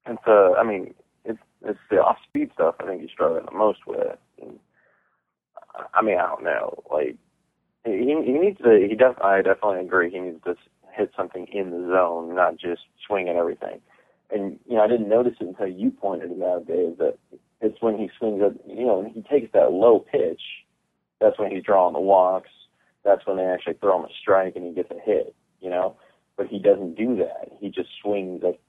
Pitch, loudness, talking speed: 110 Hz, -23 LUFS, 215 wpm